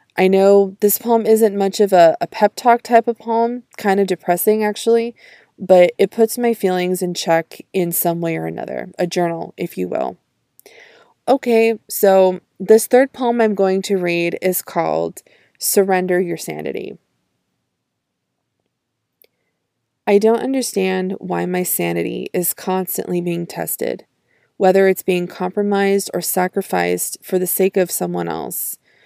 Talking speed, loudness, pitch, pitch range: 145 wpm, -17 LUFS, 190 Hz, 180-225 Hz